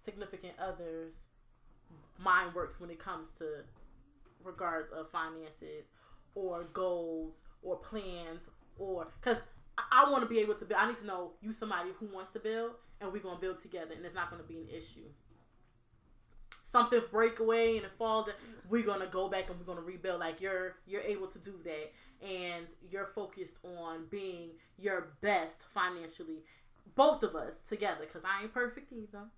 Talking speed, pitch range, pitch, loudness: 170 wpm, 165-210 Hz, 185 Hz, -36 LUFS